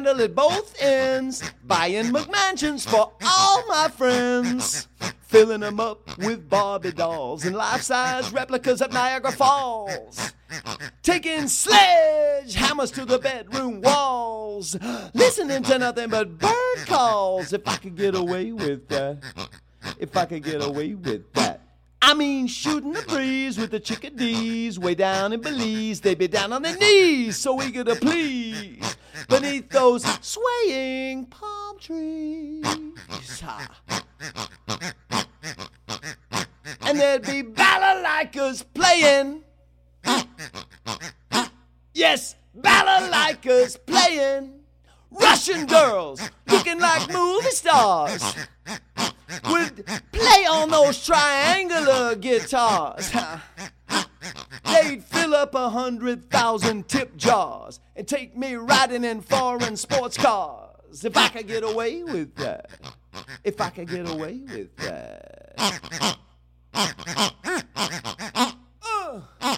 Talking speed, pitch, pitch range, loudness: 110 wpm, 260 Hz, 220-305 Hz, -21 LUFS